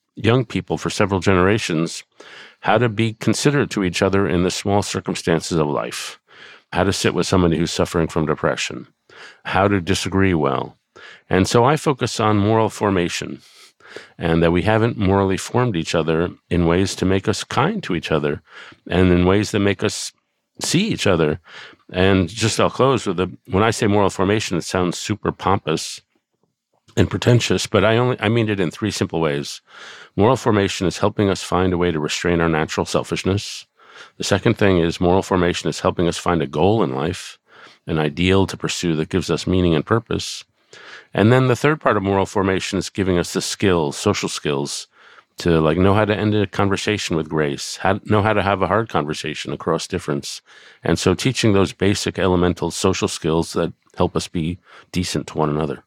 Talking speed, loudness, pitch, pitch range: 190 wpm, -19 LUFS, 95 Hz, 85-105 Hz